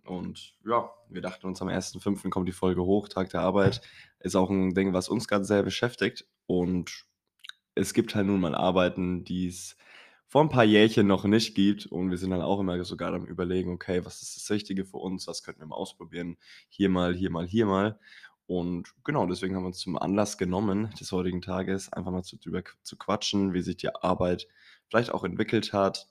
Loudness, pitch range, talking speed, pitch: -28 LUFS, 90-100 Hz, 210 wpm, 95 Hz